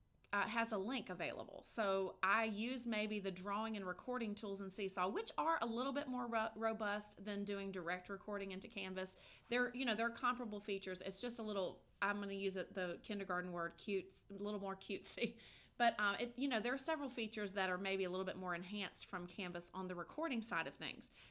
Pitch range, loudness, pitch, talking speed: 190-230 Hz, -43 LUFS, 205 Hz, 220 wpm